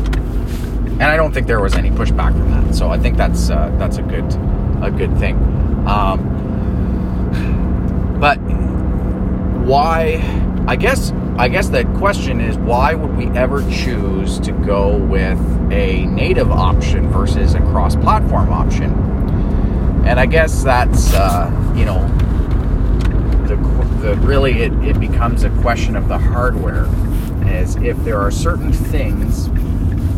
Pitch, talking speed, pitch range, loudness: 80 Hz, 135 wpm, 70-100 Hz, -16 LUFS